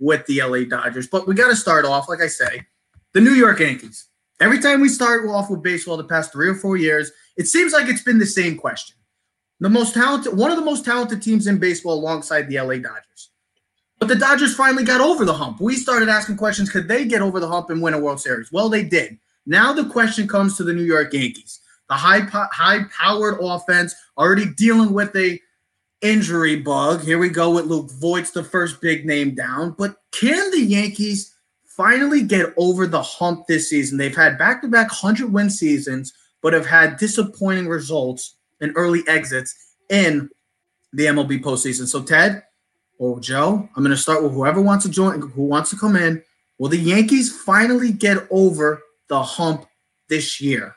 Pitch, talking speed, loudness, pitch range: 175 Hz, 200 wpm, -17 LUFS, 150-210 Hz